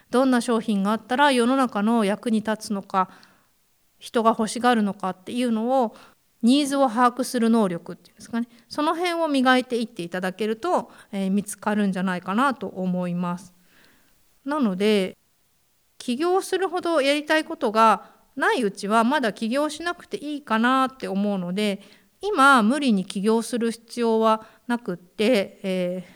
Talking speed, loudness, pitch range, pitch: 330 characters per minute, -23 LUFS, 200-260 Hz, 225 Hz